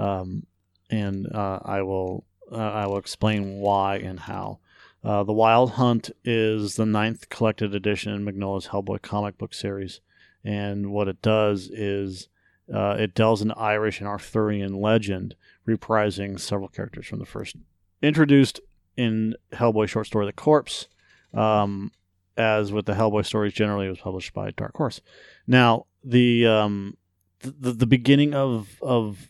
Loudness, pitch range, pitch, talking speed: -24 LUFS, 100-110 Hz, 105 Hz, 155 wpm